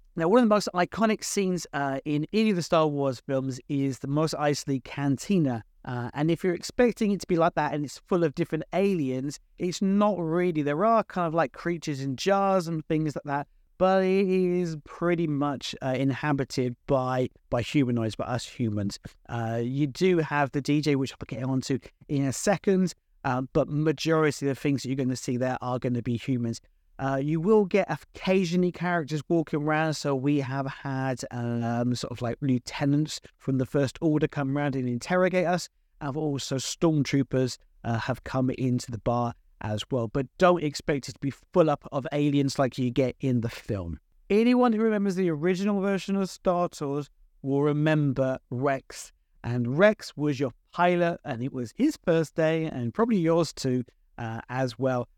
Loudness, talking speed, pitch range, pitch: -27 LUFS, 190 wpm, 130-170 Hz, 145 Hz